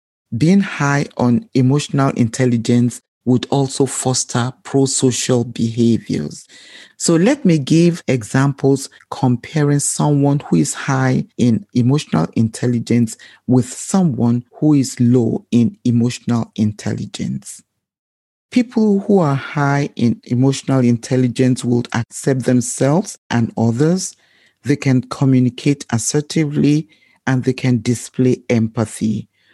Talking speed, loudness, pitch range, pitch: 110 wpm, -17 LUFS, 120-140 Hz, 130 Hz